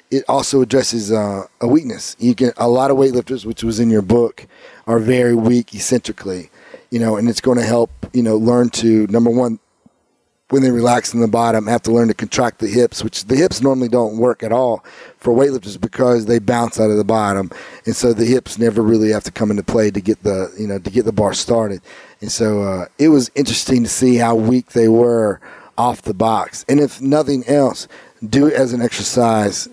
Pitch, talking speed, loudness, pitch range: 115 Hz, 220 wpm, -16 LUFS, 110-125 Hz